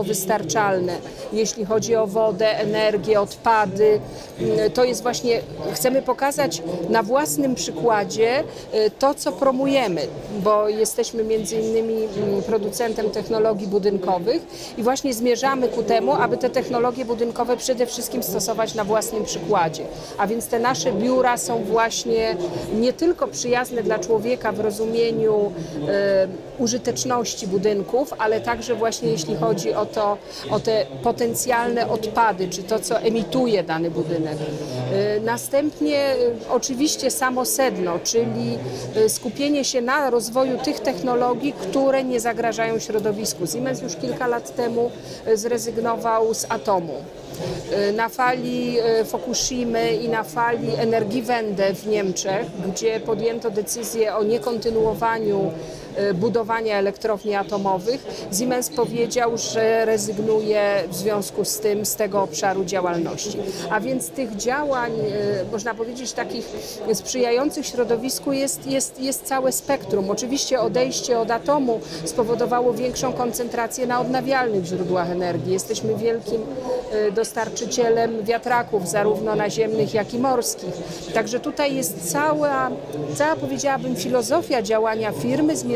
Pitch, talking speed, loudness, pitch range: 225 Hz, 120 wpm, -22 LUFS, 210-245 Hz